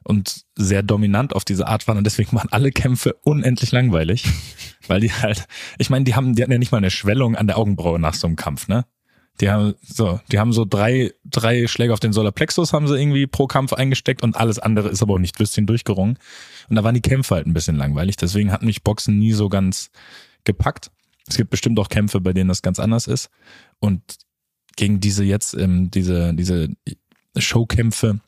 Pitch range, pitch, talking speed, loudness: 100-120 Hz, 110 Hz, 210 wpm, -19 LUFS